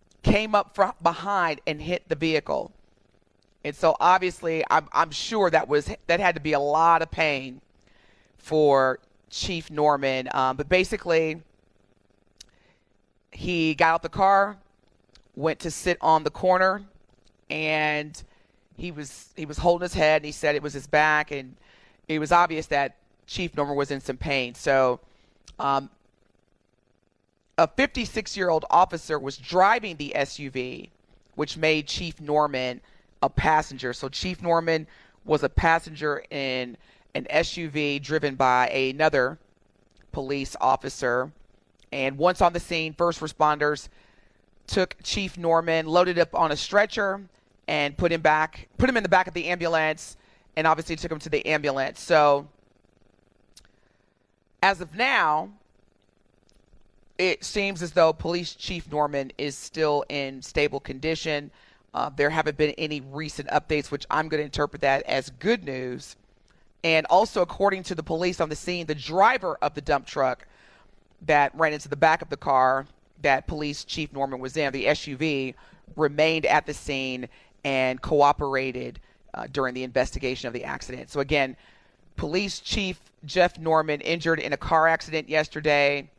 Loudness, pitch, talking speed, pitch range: -24 LUFS, 150 Hz, 155 wpm, 130-165 Hz